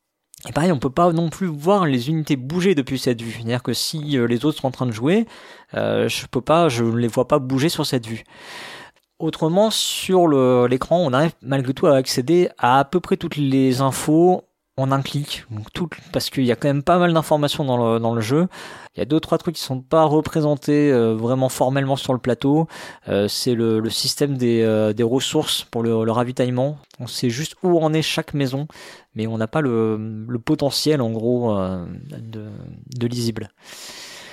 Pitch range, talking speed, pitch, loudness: 120-155 Hz, 210 wpm, 135 Hz, -20 LUFS